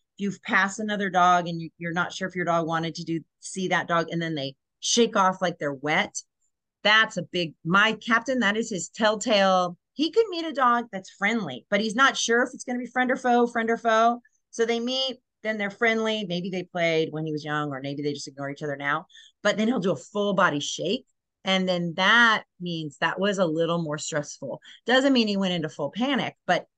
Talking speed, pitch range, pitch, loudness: 235 wpm, 165-230 Hz, 190 Hz, -24 LUFS